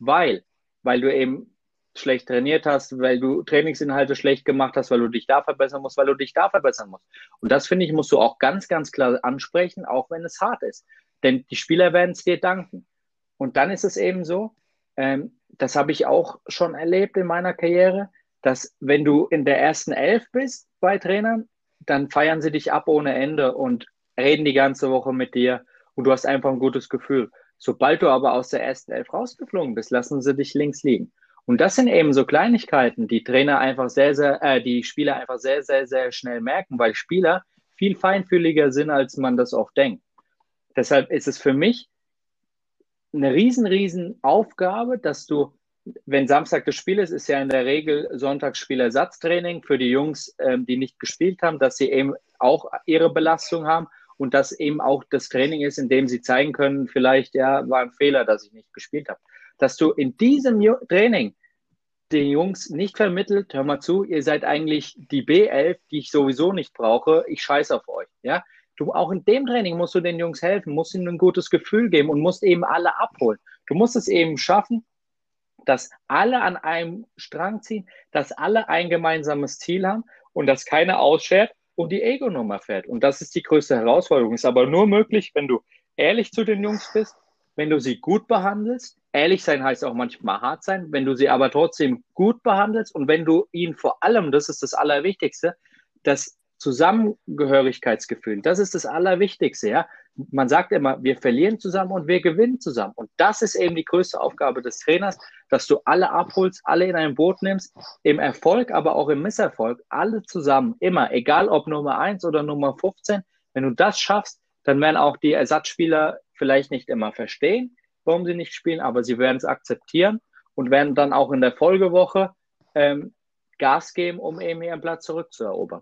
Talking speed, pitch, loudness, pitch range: 195 wpm, 160 Hz, -21 LUFS, 140-195 Hz